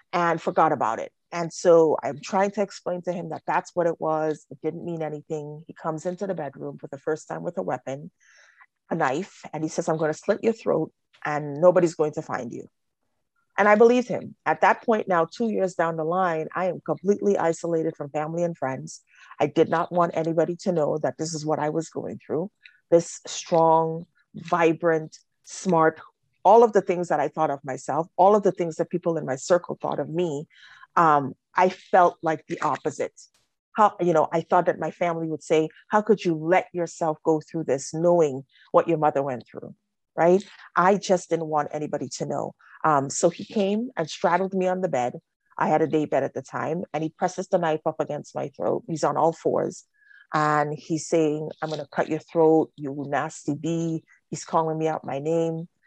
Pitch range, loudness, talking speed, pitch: 155-180 Hz, -24 LUFS, 210 wpm, 165 Hz